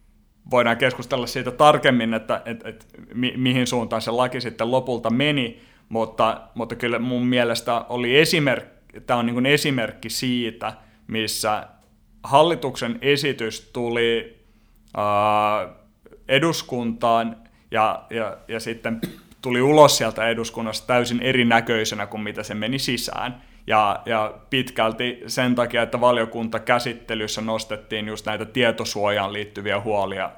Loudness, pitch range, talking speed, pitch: -22 LUFS, 110-125 Hz, 125 wpm, 115 Hz